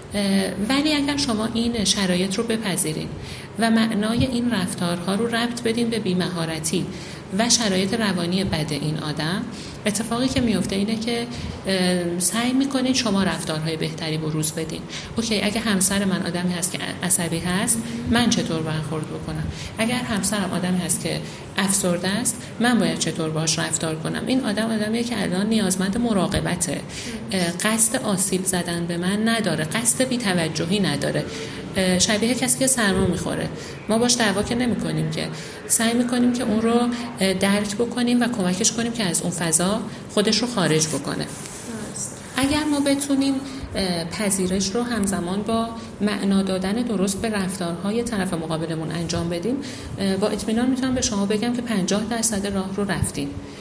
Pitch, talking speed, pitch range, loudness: 205 Hz, 150 wpm, 175-230 Hz, -22 LUFS